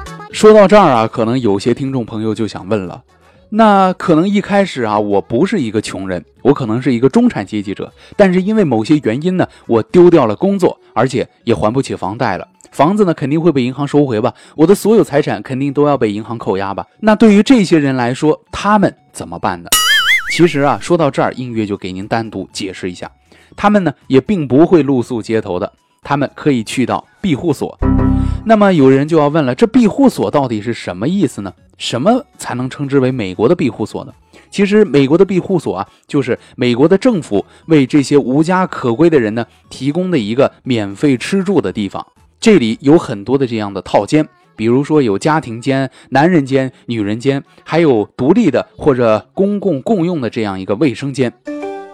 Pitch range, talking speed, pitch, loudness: 115-175 Hz, 305 characters per minute, 140 Hz, -13 LUFS